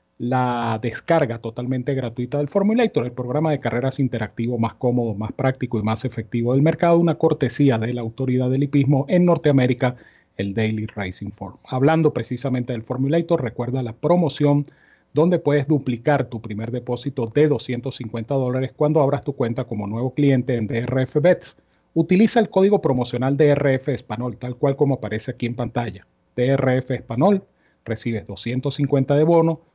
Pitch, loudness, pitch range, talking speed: 130 Hz, -21 LUFS, 120-145 Hz, 155 wpm